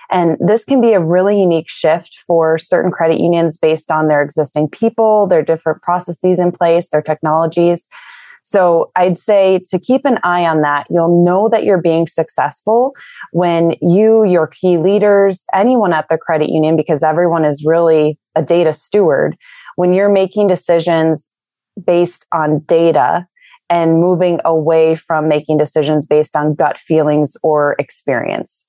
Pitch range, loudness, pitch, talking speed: 155-185 Hz, -13 LUFS, 170 Hz, 155 wpm